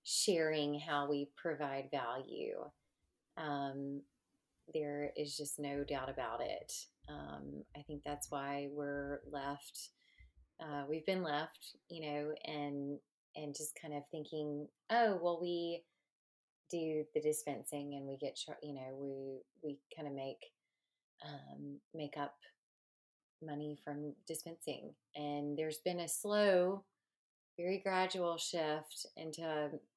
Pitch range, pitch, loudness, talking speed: 140-160 Hz, 150 Hz, -41 LUFS, 130 wpm